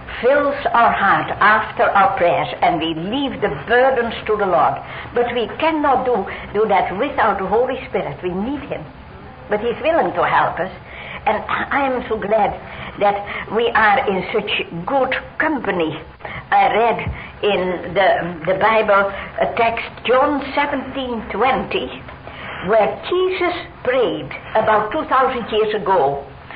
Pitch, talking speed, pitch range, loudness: 230 Hz, 140 wpm, 200-265 Hz, -18 LUFS